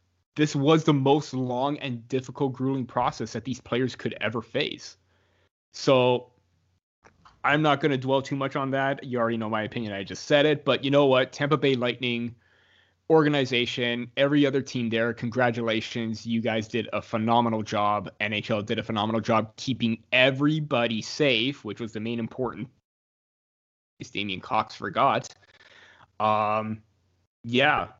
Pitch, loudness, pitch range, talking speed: 120 Hz, -25 LUFS, 110-135 Hz, 155 wpm